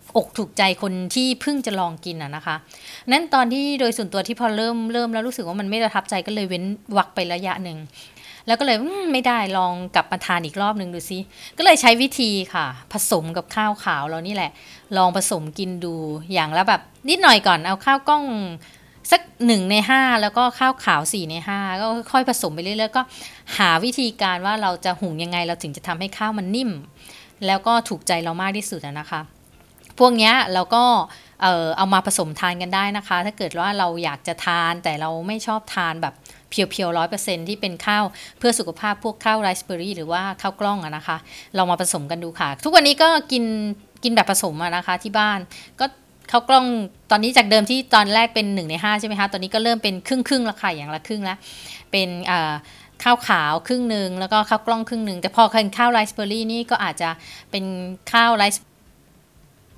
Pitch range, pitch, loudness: 180-230 Hz, 200 Hz, -20 LUFS